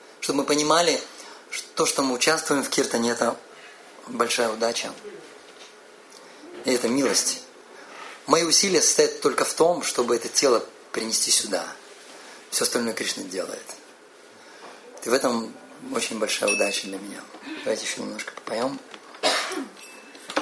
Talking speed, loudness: 125 wpm, -23 LUFS